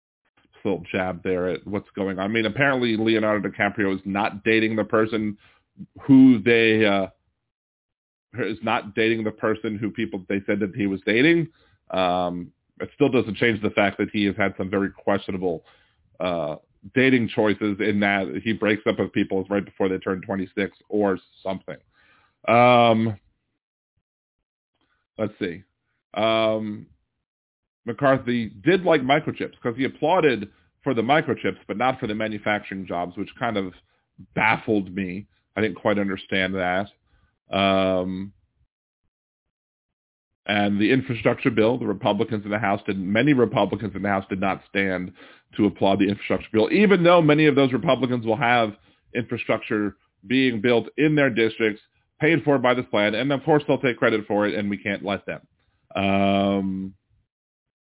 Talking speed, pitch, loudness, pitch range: 160 wpm, 105 Hz, -22 LUFS, 95-115 Hz